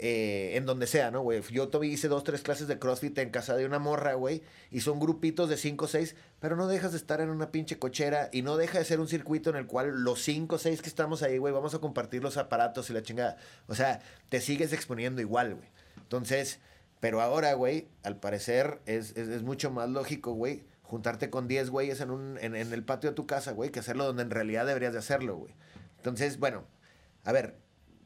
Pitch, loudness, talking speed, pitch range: 135 Hz, -32 LUFS, 230 wpm, 120-150 Hz